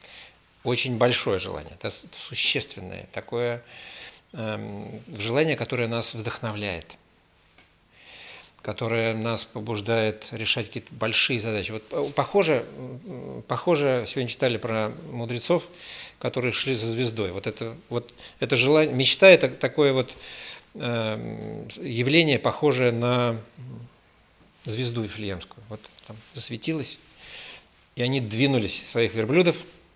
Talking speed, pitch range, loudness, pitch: 100 wpm, 110-130 Hz, -25 LUFS, 120 Hz